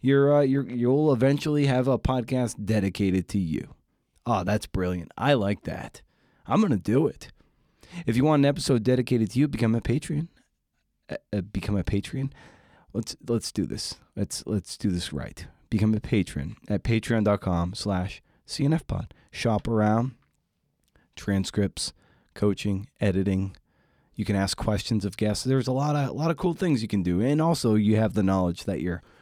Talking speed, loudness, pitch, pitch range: 170 wpm, -26 LUFS, 110 Hz, 100-130 Hz